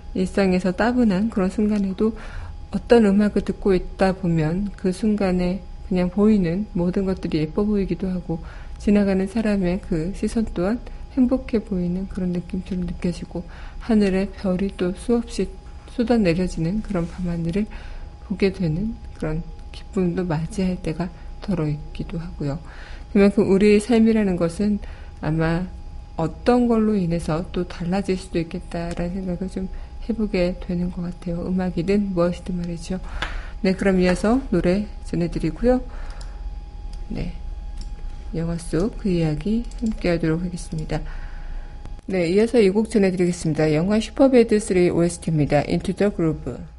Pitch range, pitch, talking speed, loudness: 170-205 Hz, 185 Hz, 310 characters per minute, -22 LUFS